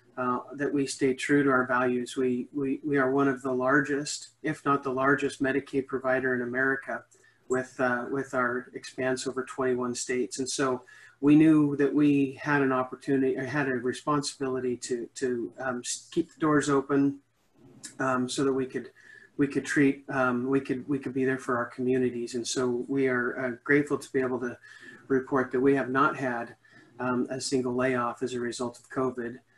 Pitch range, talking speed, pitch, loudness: 125-140 Hz, 195 wpm, 130 Hz, -28 LUFS